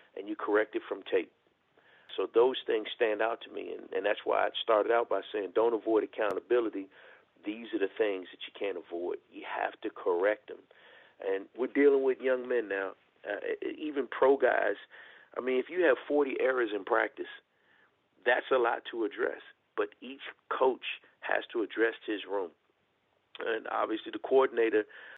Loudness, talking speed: -31 LUFS, 180 wpm